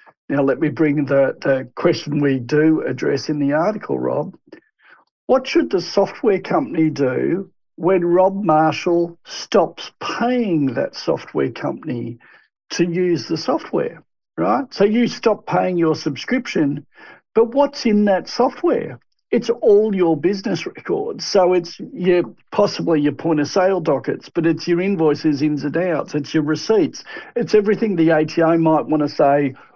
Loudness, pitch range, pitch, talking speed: -19 LUFS, 155-215 Hz, 170 Hz, 155 wpm